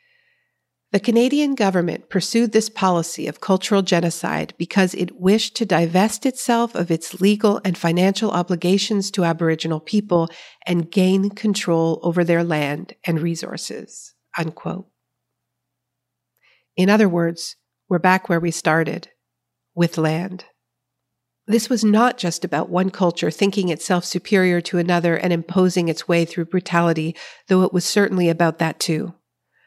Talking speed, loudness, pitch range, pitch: 140 wpm, -20 LUFS, 165-200 Hz, 180 Hz